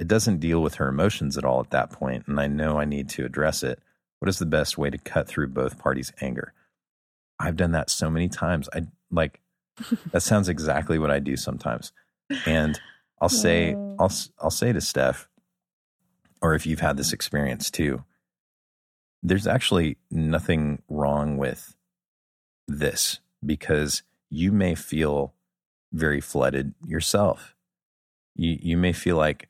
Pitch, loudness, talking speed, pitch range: 75 Hz, -25 LUFS, 160 wpm, 70-85 Hz